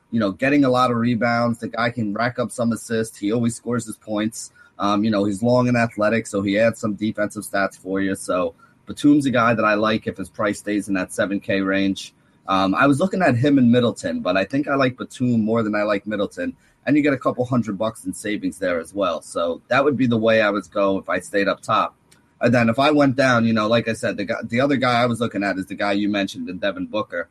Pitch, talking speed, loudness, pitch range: 115 Hz, 270 wpm, -21 LUFS, 105-125 Hz